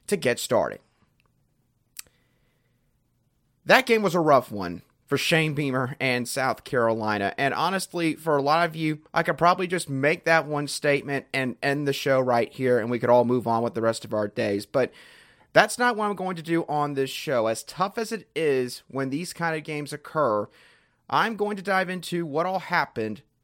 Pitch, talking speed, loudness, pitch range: 145 Hz, 200 wpm, -25 LUFS, 125-170 Hz